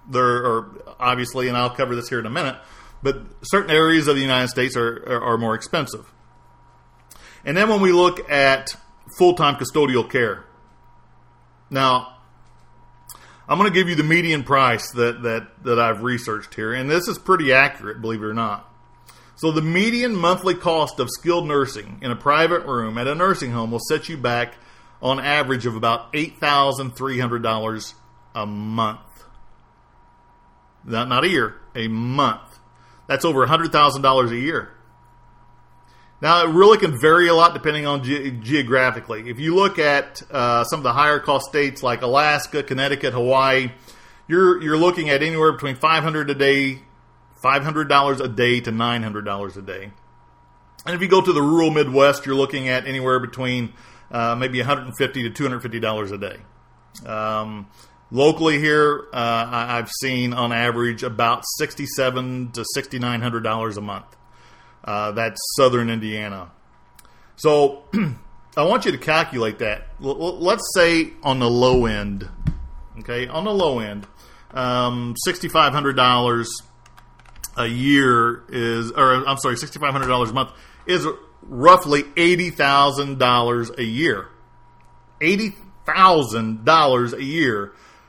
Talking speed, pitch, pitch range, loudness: 160 wpm, 125 Hz, 120-150 Hz, -19 LUFS